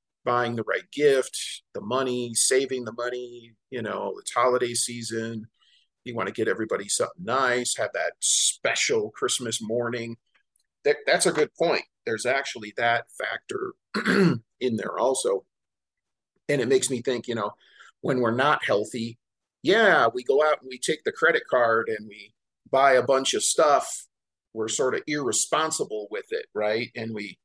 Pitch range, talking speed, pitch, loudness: 115-170 Hz, 165 wpm, 125 Hz, -25 LUFS